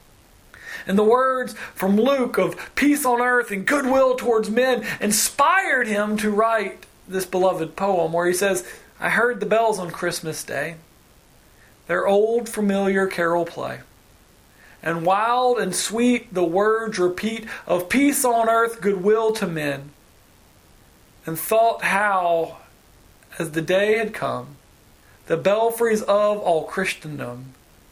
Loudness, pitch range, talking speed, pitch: -21 LUFS, 170-225 Hz, 135 wpm, 195 Hz